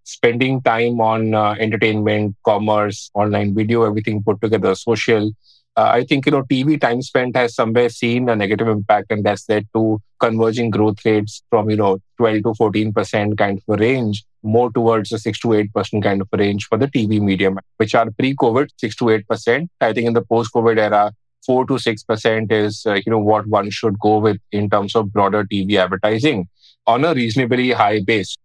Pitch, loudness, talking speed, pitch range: 110 Hz, -17 LUFS, 195 wpm, 105-120 Hz